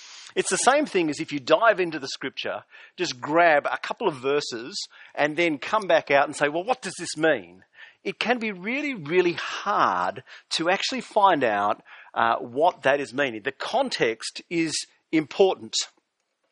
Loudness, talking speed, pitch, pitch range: -24 LUFS, 175 wpm, 175 Hz, 155-245 Hz